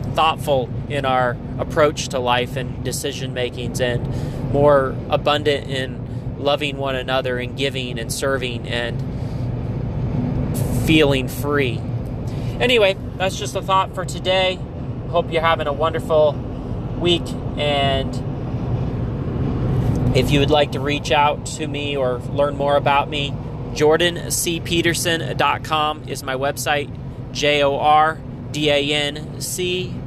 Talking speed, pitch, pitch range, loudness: 110 wpm, 135 Hz, 125-145 Hz, -20 LUFS